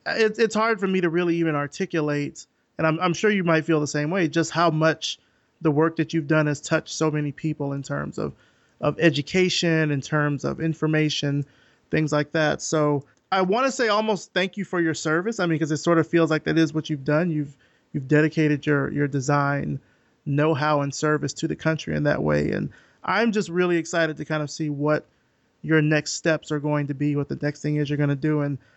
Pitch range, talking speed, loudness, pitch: 145-165 Hz, 225 wpm, -23 LUFS, 155 Hz